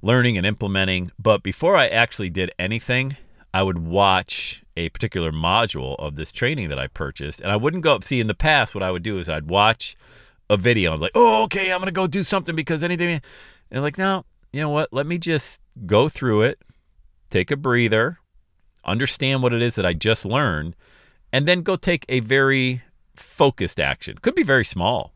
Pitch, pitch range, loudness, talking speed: 115 Hz, 95-150 Hz, -21 LUFS, 210 wpm